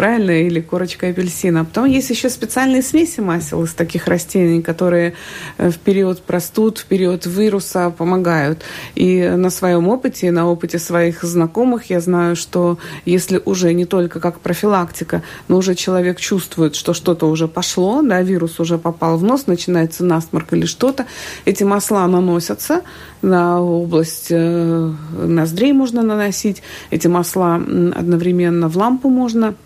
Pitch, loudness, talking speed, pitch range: 180 Hz, -16 LUFS, 145 wpm, 170-200 Hz